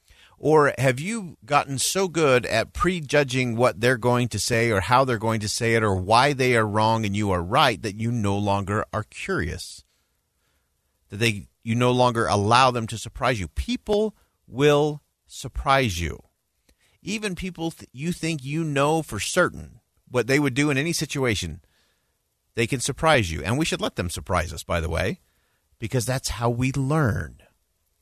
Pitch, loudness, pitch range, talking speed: 120 Hz, -23 LUFS, 100-145 Hz, 180 wpm